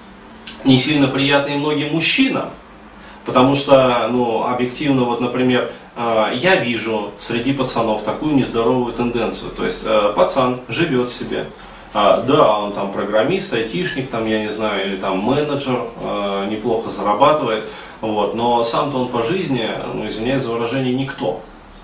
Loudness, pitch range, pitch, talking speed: -18 LUFS, 110-135 Hz, 120 Hz, 130 wpm